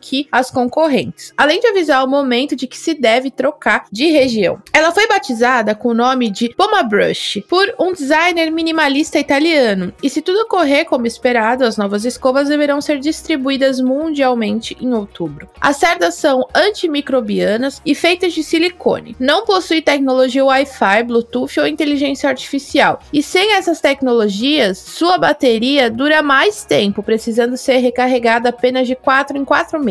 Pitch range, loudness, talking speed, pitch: 245-315 Hz, -14 LUFS, 155 wpm, 275 Hz